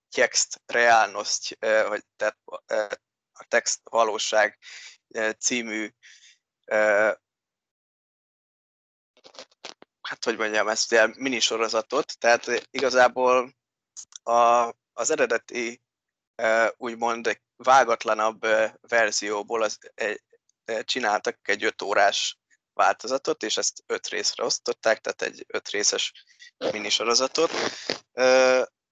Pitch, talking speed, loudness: 120 Hz, 85 wpm, -24 LUFS